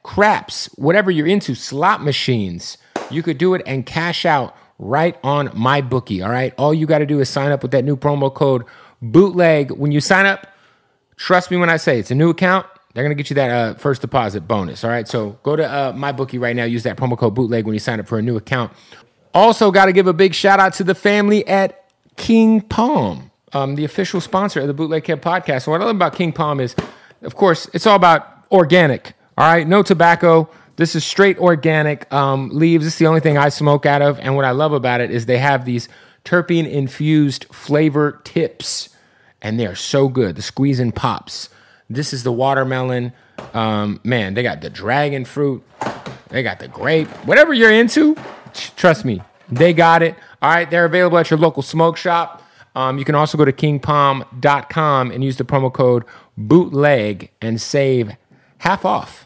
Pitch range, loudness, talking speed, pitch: 130-170 Hz, -16 LUFS, 210 wpm, 145 Hz